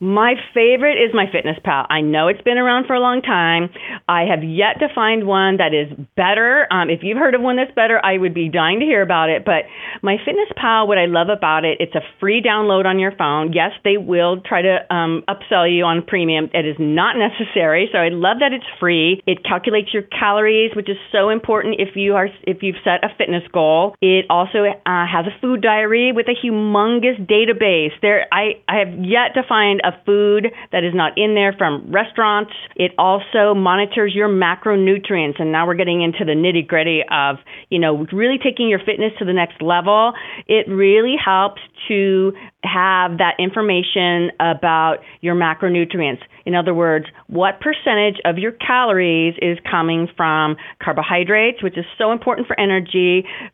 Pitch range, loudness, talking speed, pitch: 175-215 Hz, -16 LUFS, 195 wpm, 195 Hz